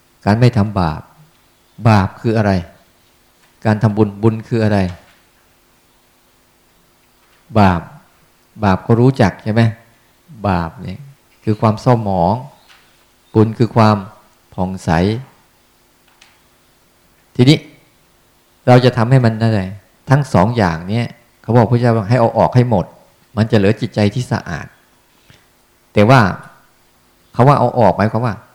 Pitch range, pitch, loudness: 95-120 Hz, 110 Hz, -15 LUFS